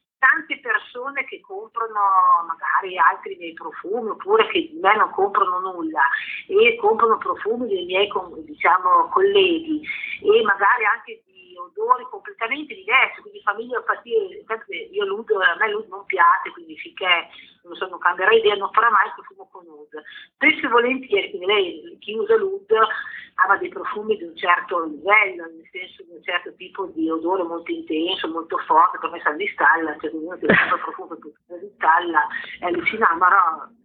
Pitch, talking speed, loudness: 280 Hz, 170 wpm, -20 LUFS